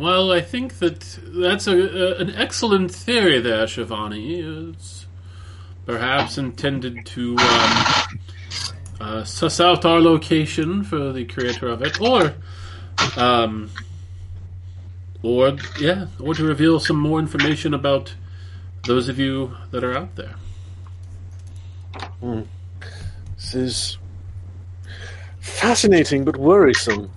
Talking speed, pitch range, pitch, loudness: 115 wpm, 90-150 Hz, 110 Hz, -19 LUFS